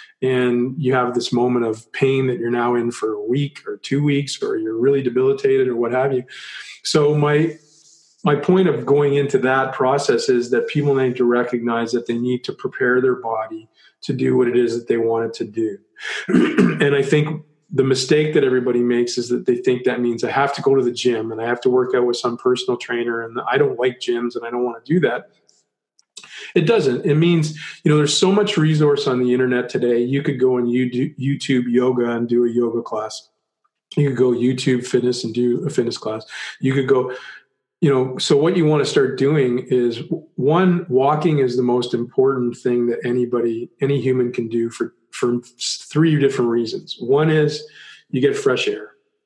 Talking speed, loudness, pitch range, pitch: 210 wpm, -19 LUFS, 120-150 Hz, 130 Hz